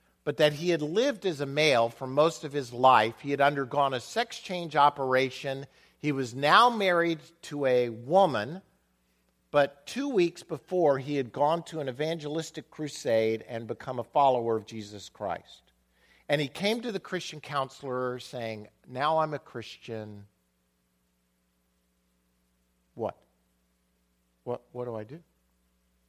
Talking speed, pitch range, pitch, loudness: 145 wpm, 105-155 Hz, 130 Hz, -28 LUFS